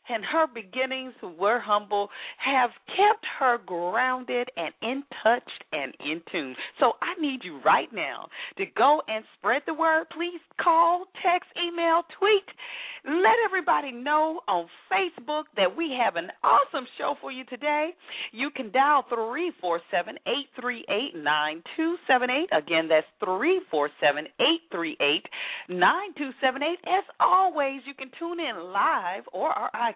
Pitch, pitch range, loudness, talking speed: 285 Hz, 240-340 Hz, -26 LUFS, 135 wpm